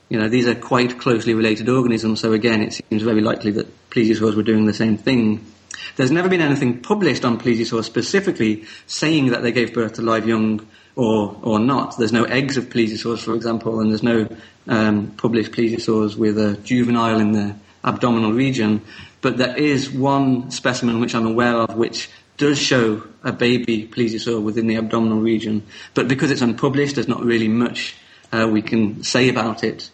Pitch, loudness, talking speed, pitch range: 115 Hz, -19 LUFS, 185 wpm, 110-125 Hz